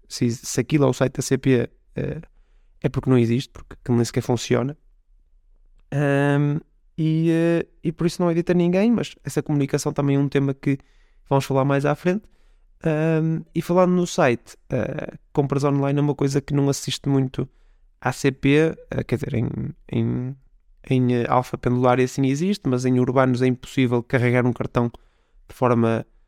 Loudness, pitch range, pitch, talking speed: -22 LUFS, 125-150 Hz, 135 Hz, 185 wpm